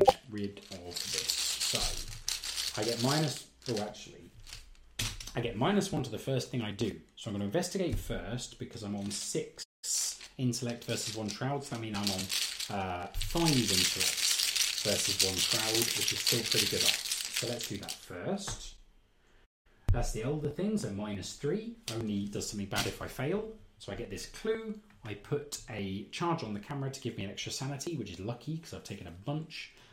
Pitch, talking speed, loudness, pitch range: 115 Hz, 190 wpm, -33 LUFS, 100-135 Hz